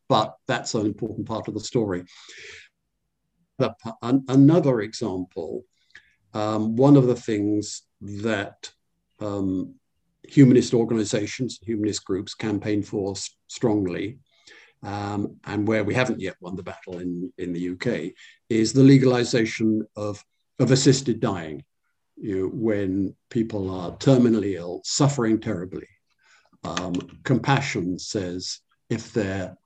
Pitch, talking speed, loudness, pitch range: 110 Hz, 120 wpm, -23 LUFS, 100-120 Hz